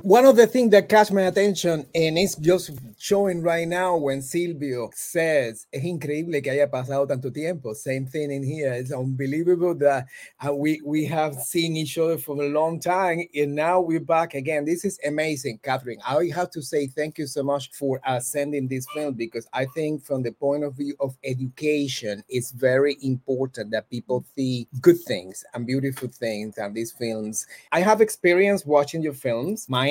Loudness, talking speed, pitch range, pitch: -24 LUFS, 185 wpm, 130-165 Hz, 145 Hz